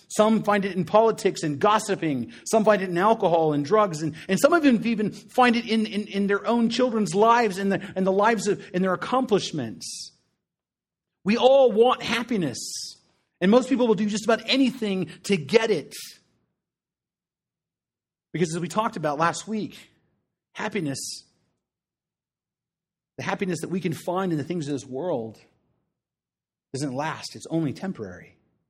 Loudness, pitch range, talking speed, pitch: -23 LUFS, 175-220 Hz, 165 wpm, 200 Hz